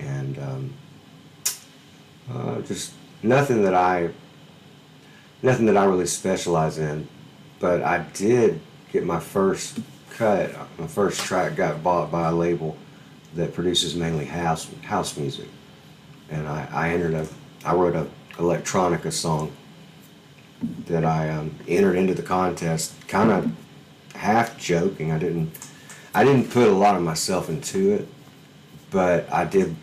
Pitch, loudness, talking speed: 90 Hz, -23 LUFS, 140 wpm